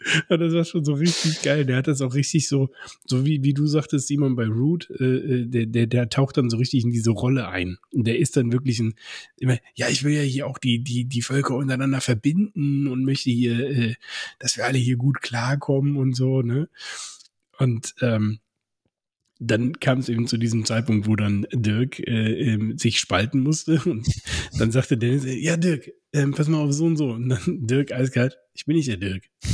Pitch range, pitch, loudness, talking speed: 120-145 Hz, 130 Hz, -23 LUFS, 210 wpm